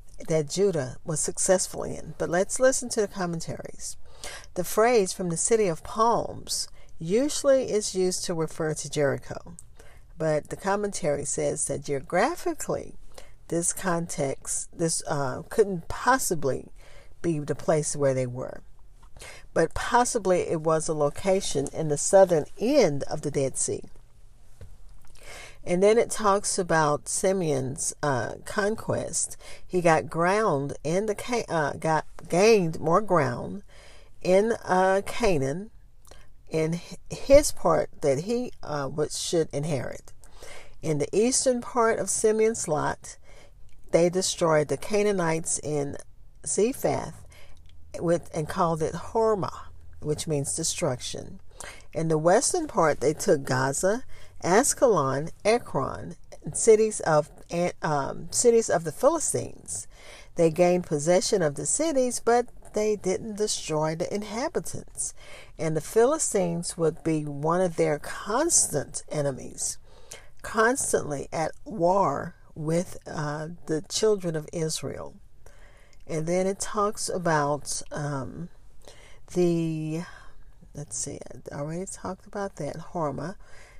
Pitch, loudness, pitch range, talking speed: 165 Hz, -26 LUFS, 145-200 Hz, 120 wpm